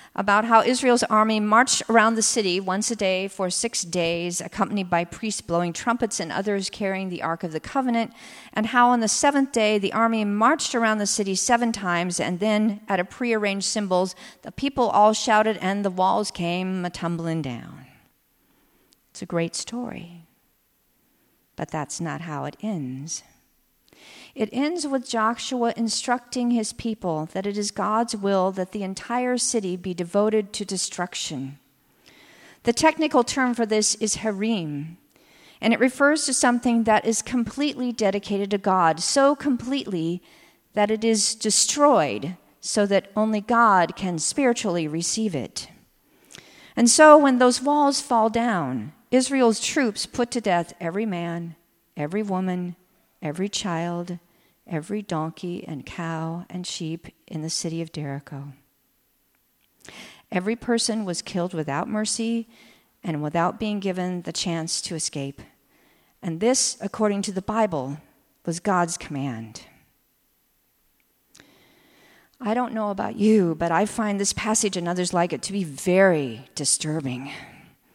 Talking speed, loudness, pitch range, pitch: 145 wpm, -23 LUFS, 175-230 Hz, 205 Hz